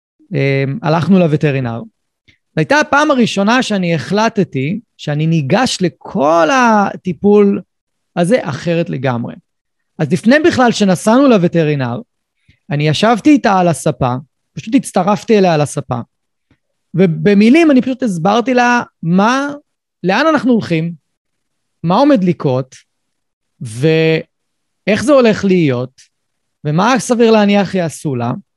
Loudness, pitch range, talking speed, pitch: -13 LUFS, 150-230 Hz, 105 wpm, 185 Hz